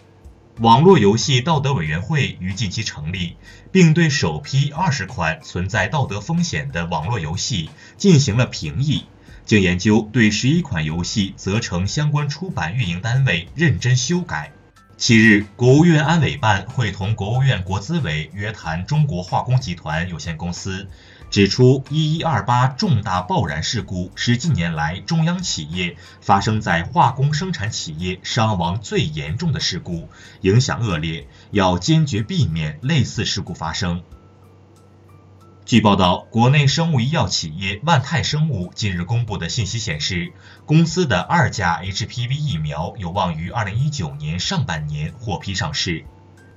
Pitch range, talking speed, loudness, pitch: 95-145 Hz, 245 characters per minute, -19 LUFS, 110 Hz